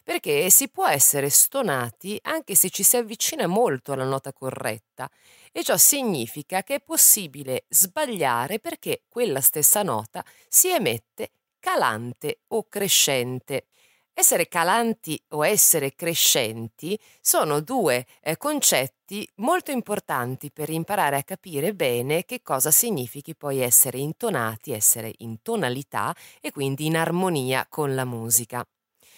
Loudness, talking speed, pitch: -21 LUFS, 125 wpm, 160 Hz